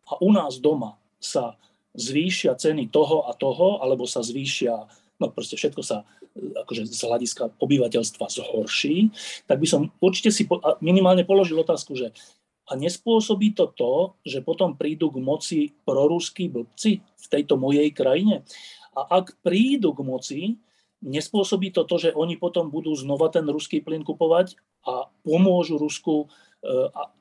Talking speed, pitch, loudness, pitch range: 150 wpm, 165 Hz, -23 LUFS, 145-195 Hz